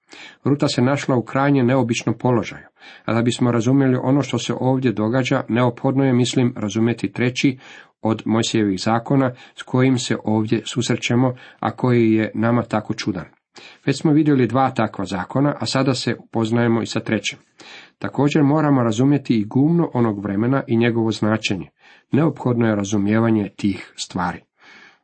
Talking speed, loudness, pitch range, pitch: 150 wpm, -19 LUFS, 110-135 Hz, 120 Hz